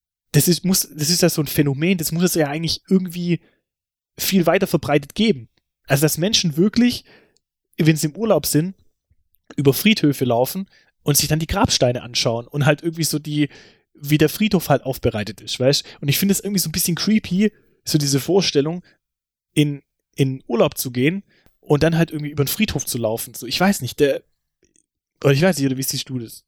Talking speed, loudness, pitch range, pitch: 200 wpm, -19 LUFS, 135-180 Hz, 150 Hz